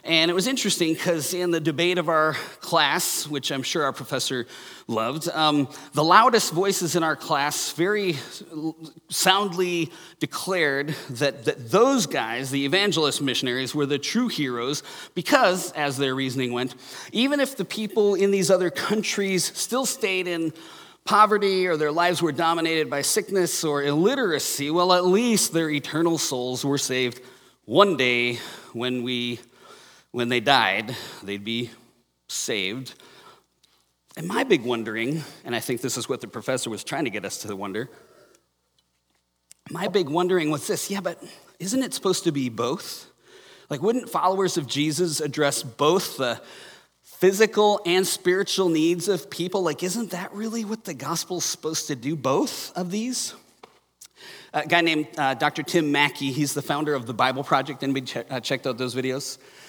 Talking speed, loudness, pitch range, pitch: 165 wpm, -23 LUFS, 135-185 Hz, 155 Hz